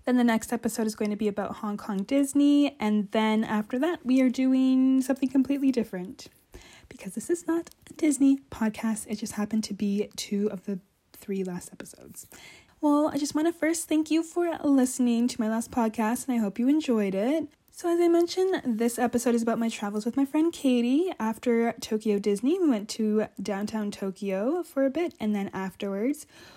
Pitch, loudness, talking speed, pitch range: 240 Hz, -27 LUFS, 200 wpm, 215-285 Hz